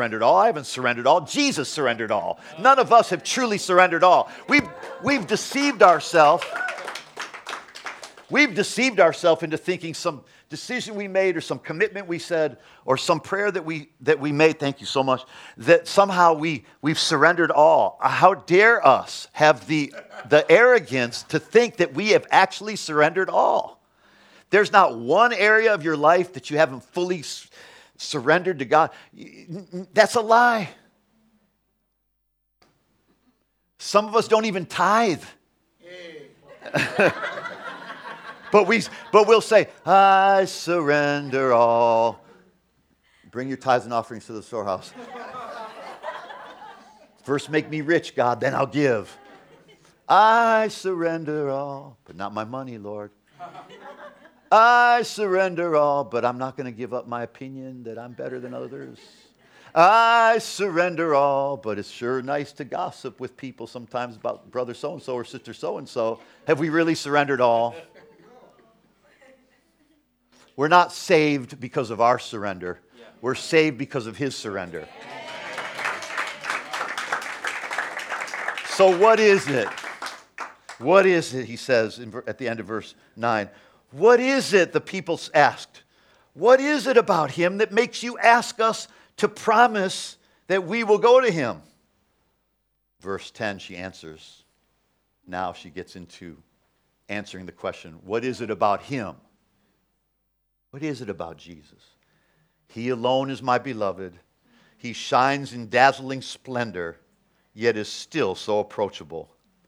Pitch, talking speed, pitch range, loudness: 155 Hz, 140 wpm, 125-200 Hz, -21 LUFS